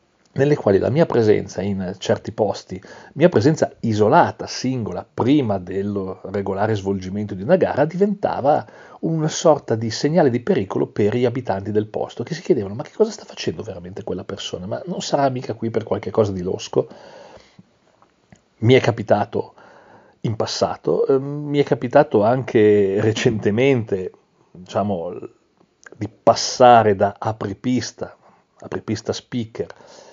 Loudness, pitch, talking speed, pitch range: -20 LUFS, 120 Hz, 140 wpm, 105-145 Hz